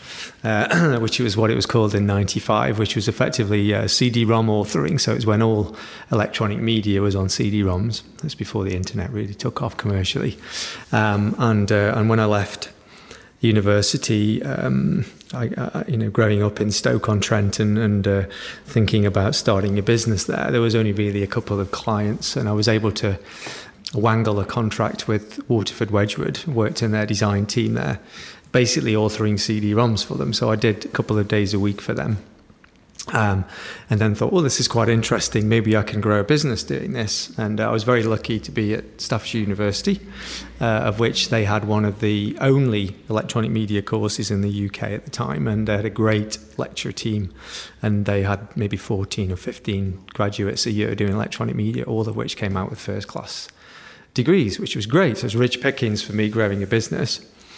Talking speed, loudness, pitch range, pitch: 195 wpm, -21 LUFS, 105-115 Hz, 110 Hz